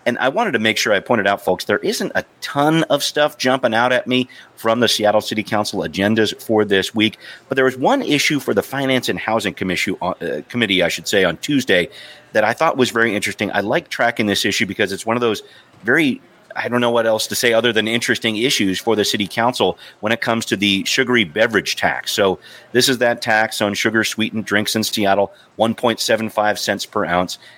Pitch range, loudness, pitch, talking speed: 105-120 Hz, -17 LUFS, 110 Hz, 220 wpm